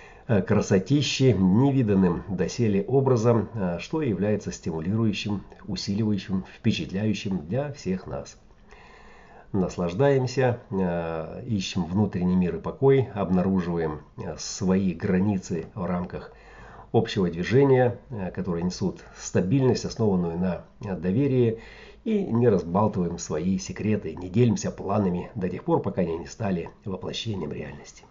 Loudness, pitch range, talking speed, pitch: -25 LUFS, 90-120 Hz, 105 wpm, 100 Hz